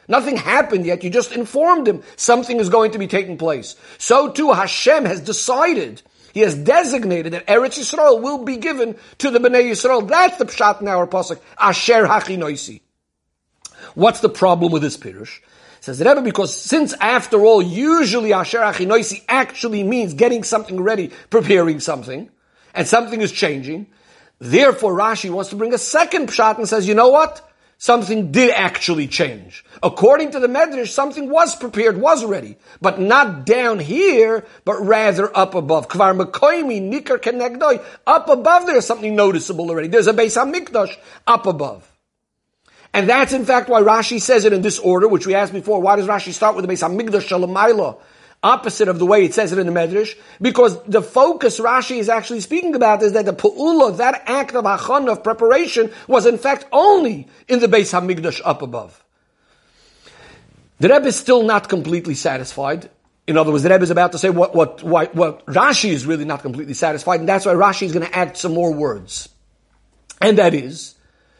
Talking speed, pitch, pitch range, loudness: 180 wpm, 220 Hz, 185-250 Hz, -16 LUFS